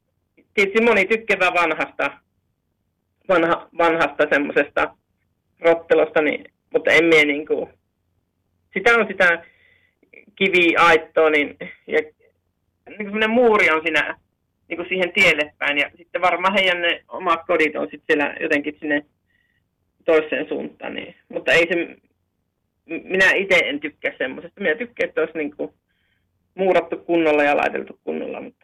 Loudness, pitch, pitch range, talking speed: -19 LUFS, 165 Hz, 145-190 Hz, 130 wpm